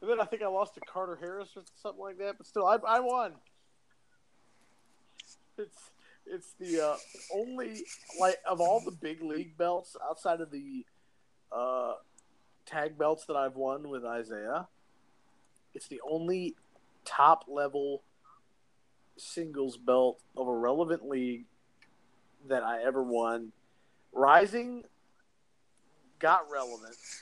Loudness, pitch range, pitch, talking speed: -31 LUFS, 135-200 Hz, 165 Hz, 130 wpm